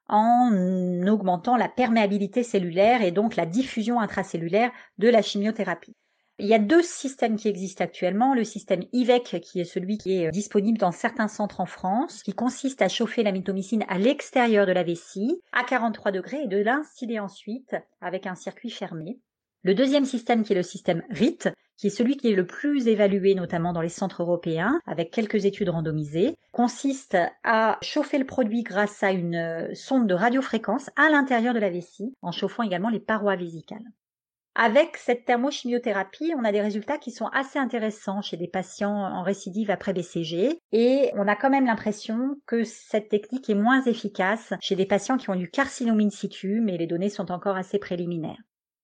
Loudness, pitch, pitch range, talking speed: -25 LUFS, 210 Hz, 190-245 Hz, 185 wpm